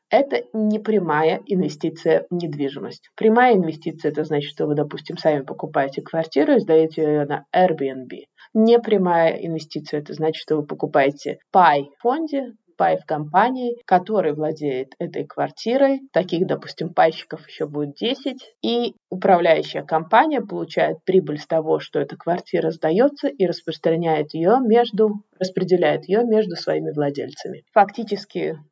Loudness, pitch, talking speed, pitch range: -21 LUFS, 170 Hz, 135 wpm, 155-215 Hz